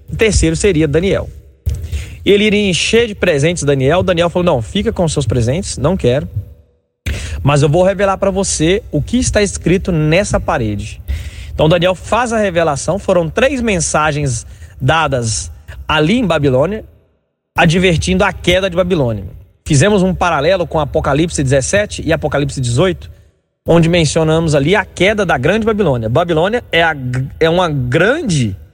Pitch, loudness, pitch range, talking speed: 155 Hz, -14 LUFS, 110-185 Hz, 150 wpm